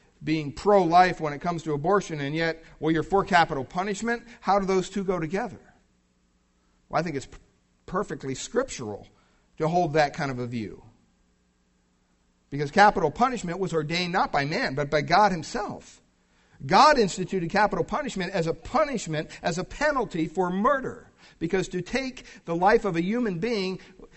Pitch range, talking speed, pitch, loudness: 140-195 Hz, 170 wpm, 170 Hz, -25 LUFS